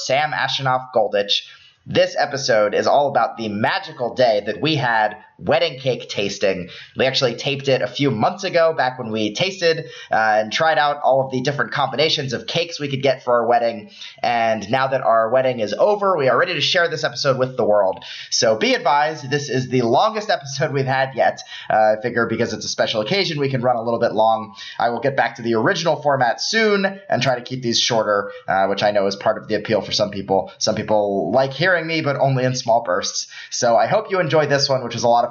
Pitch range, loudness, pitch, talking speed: 110-150 Hz, -19 LUFS, 130 Hz, 235 wpm